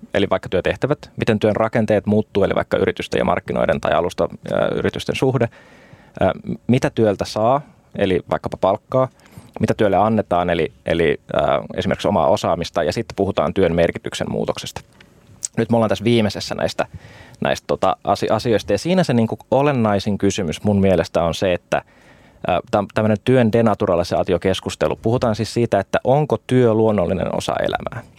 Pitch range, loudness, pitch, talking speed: 100-120 Hz, -19 LUFS, 110 Hz, 150 wpm